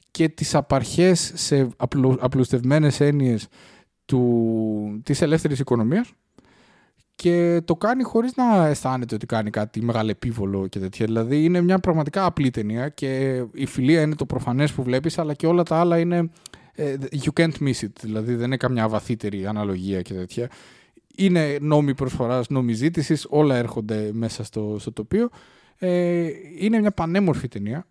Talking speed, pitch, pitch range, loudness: 150 wpm, 135 Hz, 115-165 Hz, -22 LUFS